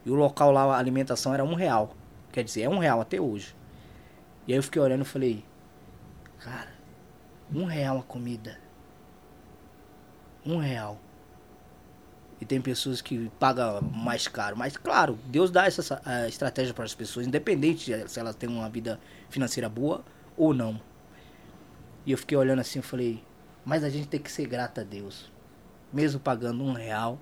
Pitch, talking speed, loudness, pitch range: 130 Hz, 165 wpm, -28 LUFS, 115-140 Hz